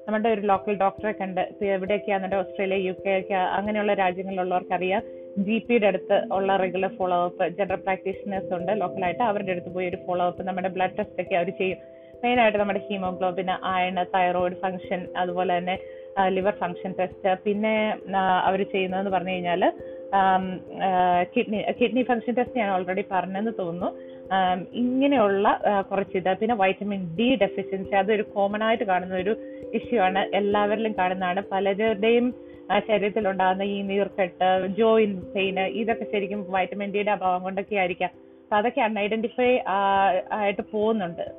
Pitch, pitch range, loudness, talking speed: 195 Hz, 185-210 Hz, -25 LUFS, 135 wpm